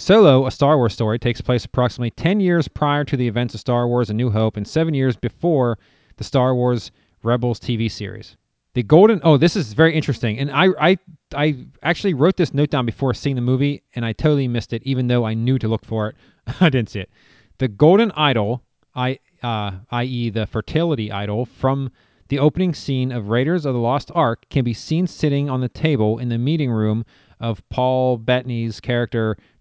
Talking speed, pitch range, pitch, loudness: 205 wpm, 115-145 Hz, 125 Hz, -19 LUFS